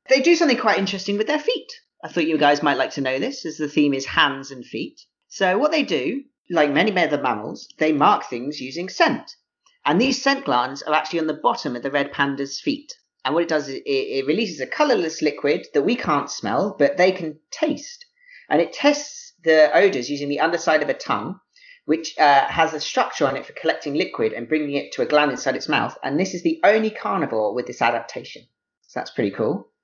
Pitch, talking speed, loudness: 180 Hz, 225 wpm, -21 LUFS